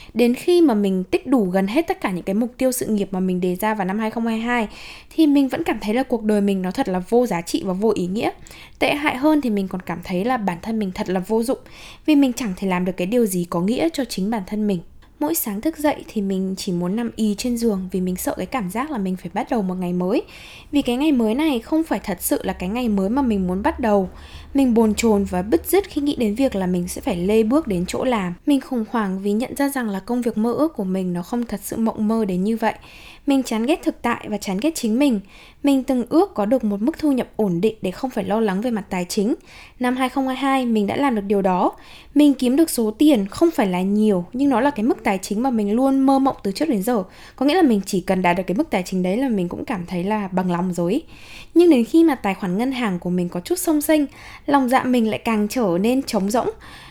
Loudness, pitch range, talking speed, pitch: -20 LUFS, 195-270 Hz, 285 wpm, 225 Hz